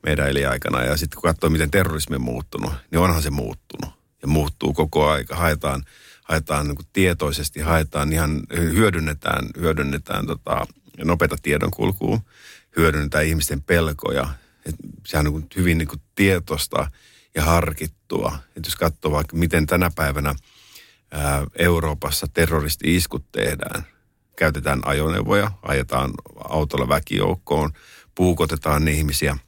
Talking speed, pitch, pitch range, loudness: 125 wpm, 75 Hz, 70-80 Hz, -22 LUFS